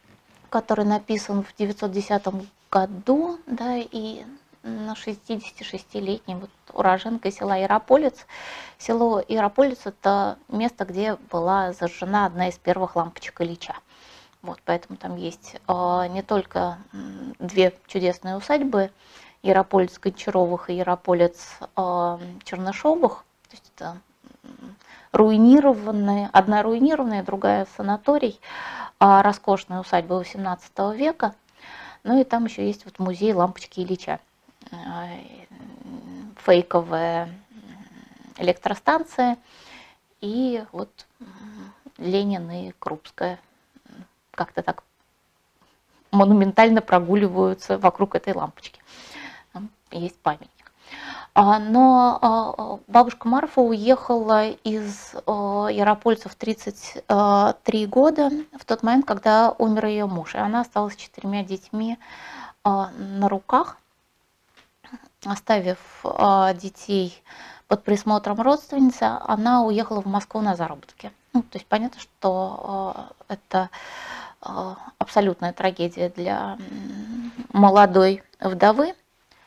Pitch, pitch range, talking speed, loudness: 205 Hz, 190-235 Hz, 95 wpm, -22 LUFS